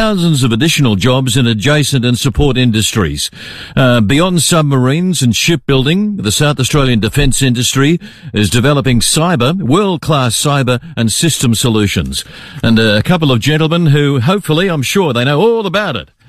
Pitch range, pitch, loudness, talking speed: 120-160 Hz, 140 Hz, -11 LUFS, 150 wpm